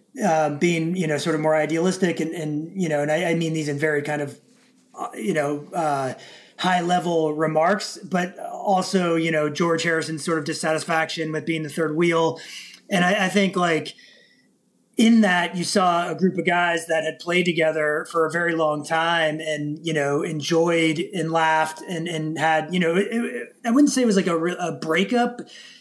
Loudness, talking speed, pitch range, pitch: -22 LUFS, 200 wpm, 155-180 Hz, 165 Hz